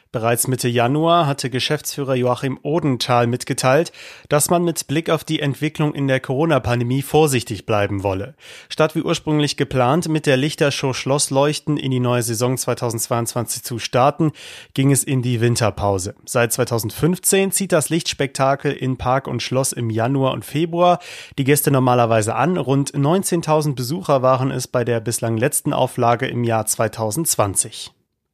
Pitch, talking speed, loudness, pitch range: 130 Hz, 150 wpm, -19 LUFS, 120-150 Hz